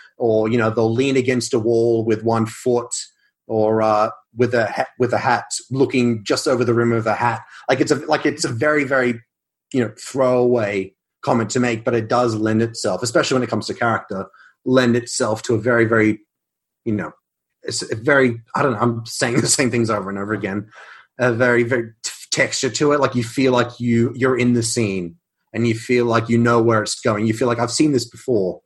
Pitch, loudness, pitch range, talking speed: 120 Hz, -19 LUFS, 115-125 Hz, 225 wpm